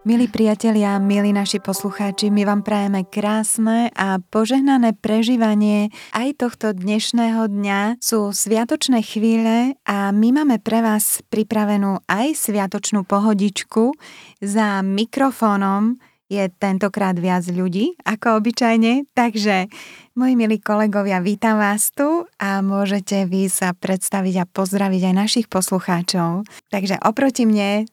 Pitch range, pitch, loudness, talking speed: 200-225 Hz, 210 Hz, -18 LUFS, 120 wpm